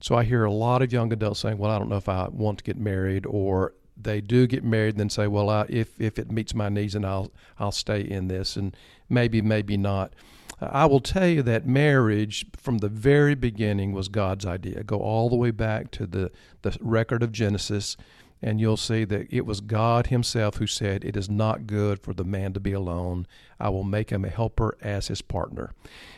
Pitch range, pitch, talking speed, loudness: 100-115 Hz, 105 Hz, 225 wpm, -25 LUFS